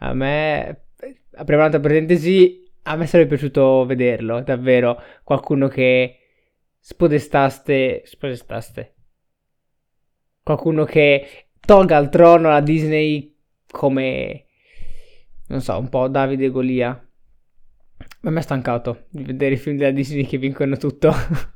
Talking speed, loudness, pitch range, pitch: 120 wpm, -17 LUFS, 130-155 Hz, 140 Hz